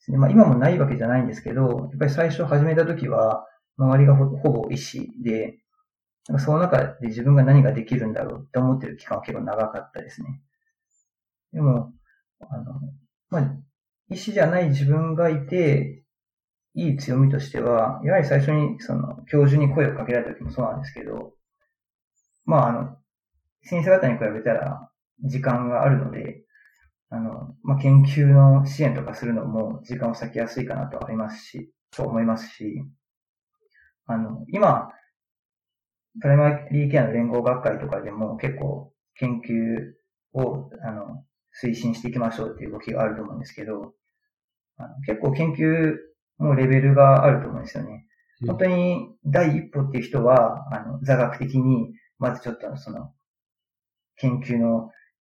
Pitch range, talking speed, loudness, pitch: 115-145 Hz, 305 characters per minute, -22 LUFS, 135 Hz